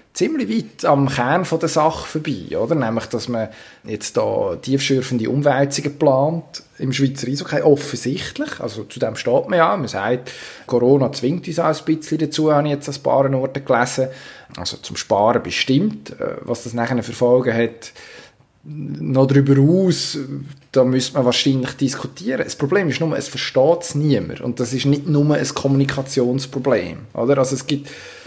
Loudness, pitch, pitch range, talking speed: -19 LUFS, 140 Hz, 125-150 Hz, 170 wpm